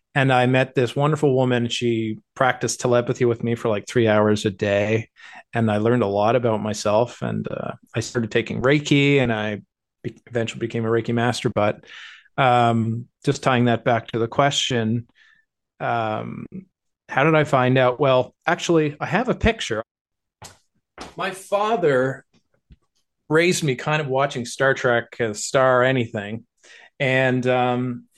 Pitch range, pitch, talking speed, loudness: 115-140 Hz, 125 Hz, 160 wpm, -21 LUFS